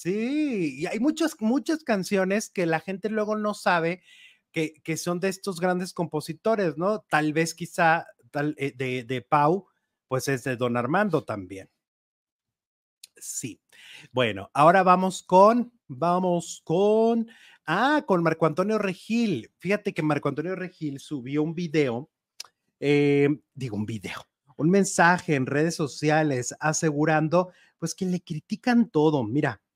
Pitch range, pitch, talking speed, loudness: 150-200 Hz, 170 Hz, 140 wpm, -25 LUFS